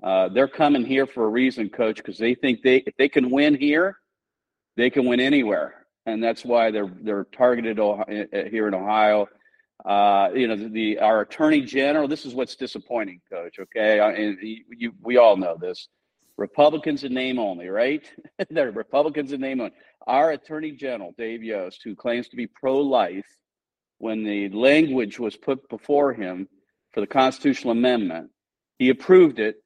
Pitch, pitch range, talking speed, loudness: 130 Hz, 110-145 Hz, 180 wpm, -22 LUFS